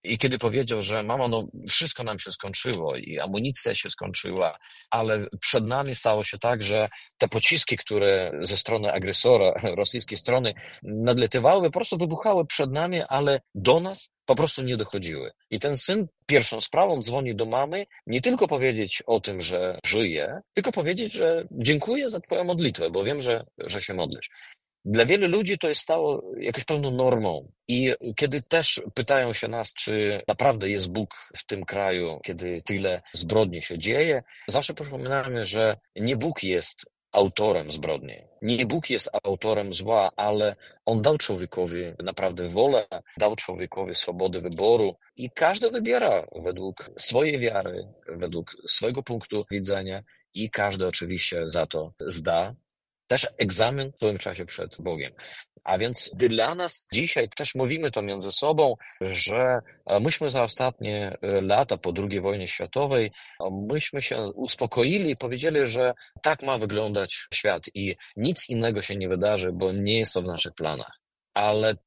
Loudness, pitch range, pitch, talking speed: -25 LUFS, 100-140 Hz, 115 Hz, 155 wpm